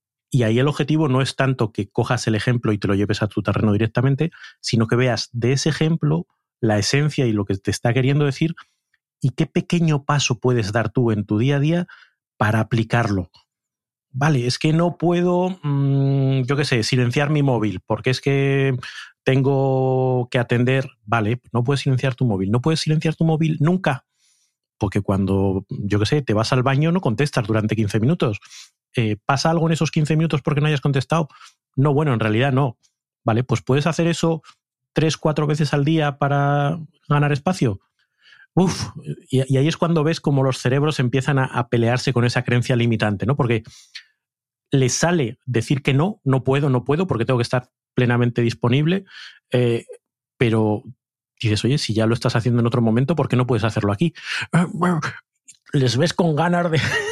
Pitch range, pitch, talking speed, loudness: 120-150 Hz, 130 Hz, 185 wpm, -20 LUFS